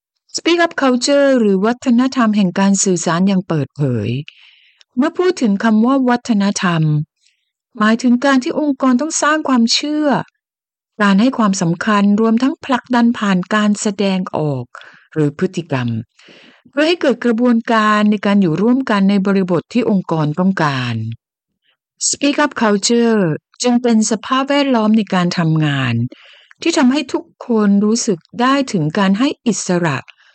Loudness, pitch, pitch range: -15 LUFS, 215 Hz, 180-255 Hz